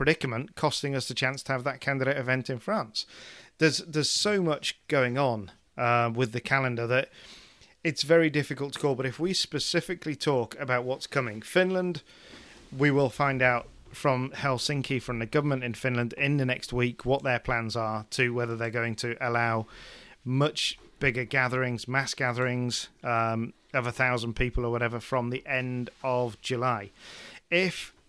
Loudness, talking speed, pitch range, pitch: -28 LUFS, 170 wpm, 120-140 Hz, 130 Hz